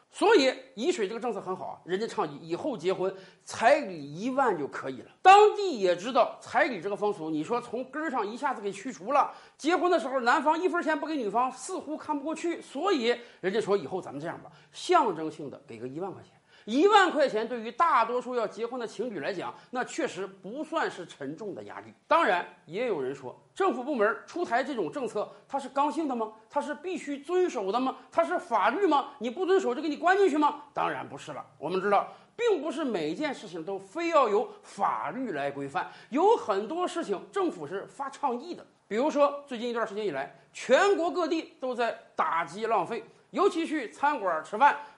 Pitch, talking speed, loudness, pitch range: 270 Hz, 310 characters per minute, -28 LUFS, 210-335 Hz